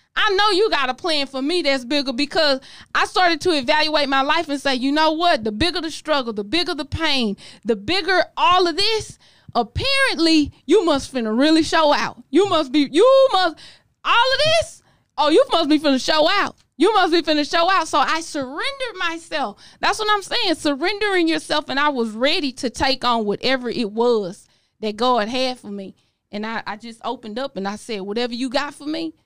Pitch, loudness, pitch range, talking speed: 300 Hz, -19 LUFS, 255-345 Hz, 210 wpm